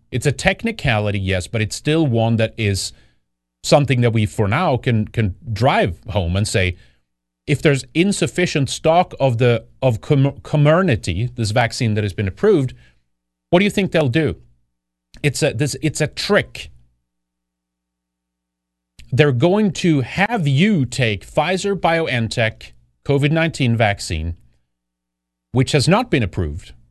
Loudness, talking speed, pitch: -18 LUFS, 140 wpm, 115 Hz